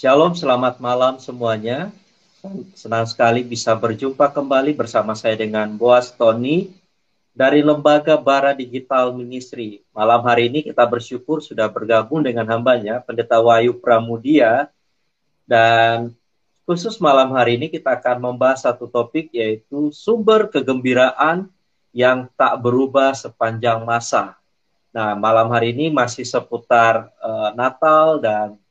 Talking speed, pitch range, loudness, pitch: 120 wpm, 115-150 Hz, -17 LUFS, 125 Hz